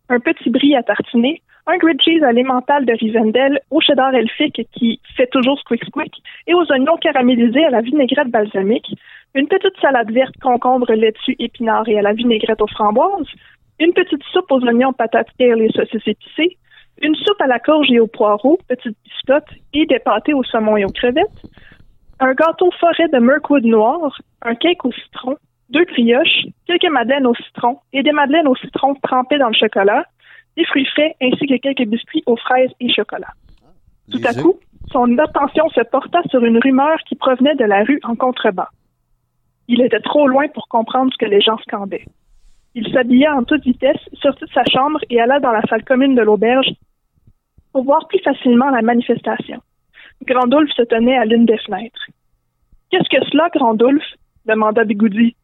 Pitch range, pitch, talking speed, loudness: 235-295 Hz, 260 Hz, 180 wpm, -15 LUFS